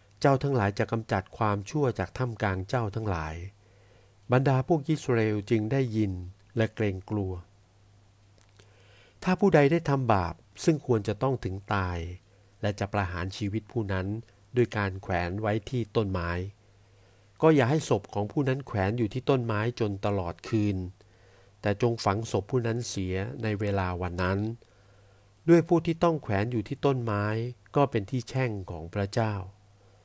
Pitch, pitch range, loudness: 105 Hz, 100-120 Hz, -28 LUFS